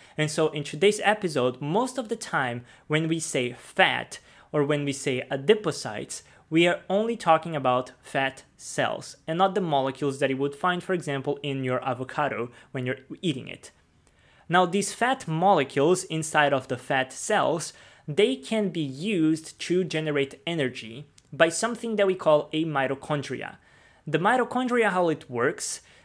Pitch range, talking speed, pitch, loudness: 135-185 Hz, 160 wpm, 155 Hz, -26 LUFS